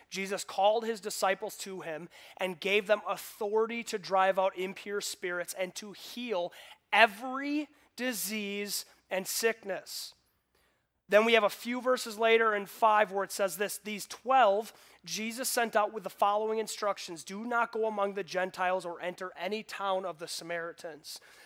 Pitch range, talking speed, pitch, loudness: 185-225 Hz, 160 wpm, 205 Hz, -31 LUFS